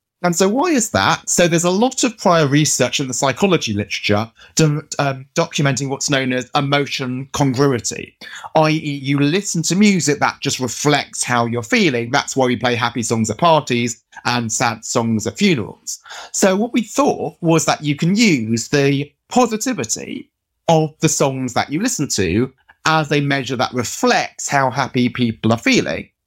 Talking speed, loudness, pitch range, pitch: 175 wpm, -17 LUFS, 125-165 Hz, 145 Hz